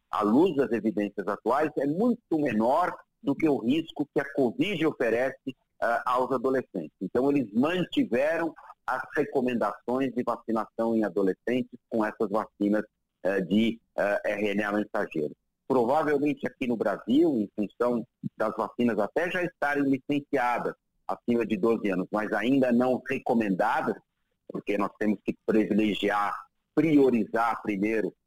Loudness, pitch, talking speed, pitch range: -27 LUFS, 120 Hz, 135 wpm, 105-140 Hz